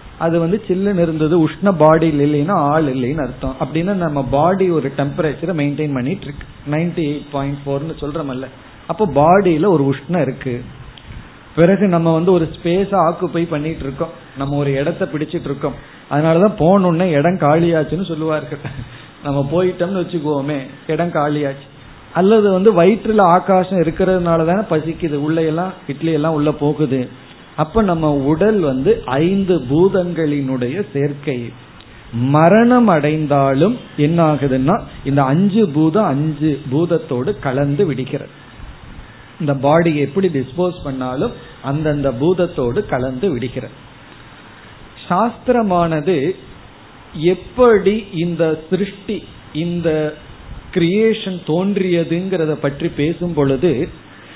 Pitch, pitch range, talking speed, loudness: 155 Hz, 140-175 Hz, 105 wpm, -16 LUFS